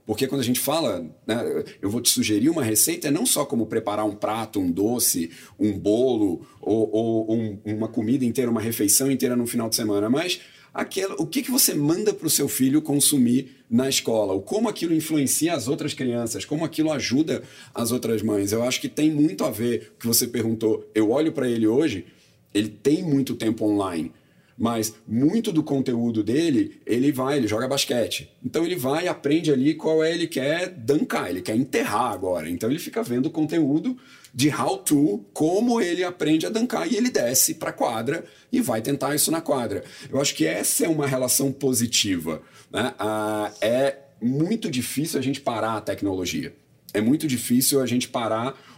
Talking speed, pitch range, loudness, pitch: 195 wpm, 115-155 Hz, -23 LUFS, 130 Hz